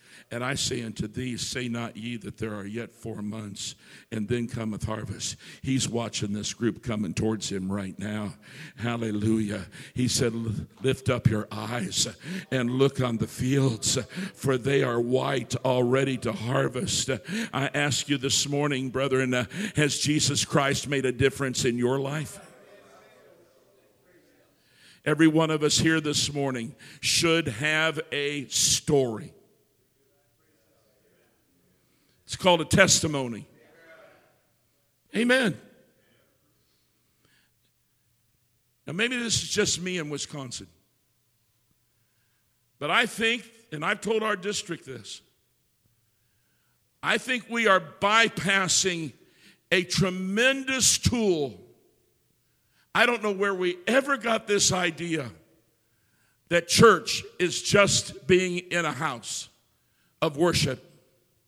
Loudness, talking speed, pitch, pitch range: -25 LUFS, 120 wpm, 135 Hz, 115-165 Hz